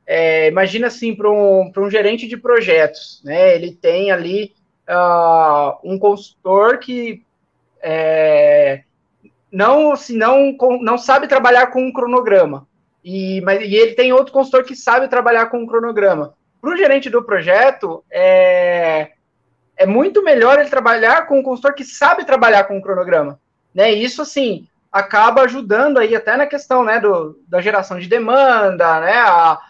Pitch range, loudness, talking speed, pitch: 185-255 Hz, -13 LUFS, 160 wpm, 215 Hz